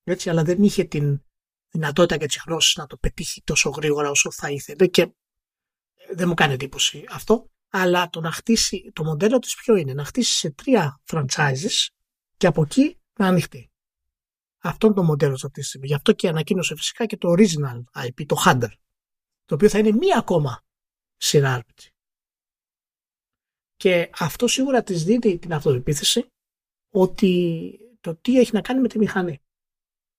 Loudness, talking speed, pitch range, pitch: -21 LUFS, 165 wpm, 150-205 Hz, 175 Hz